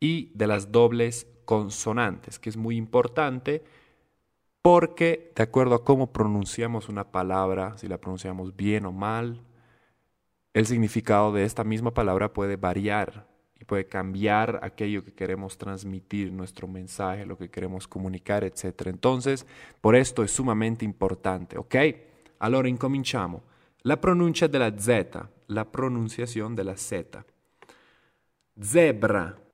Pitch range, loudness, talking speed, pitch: 95-125 Hz, -26 LUFS, 130 wpm, 110 Hz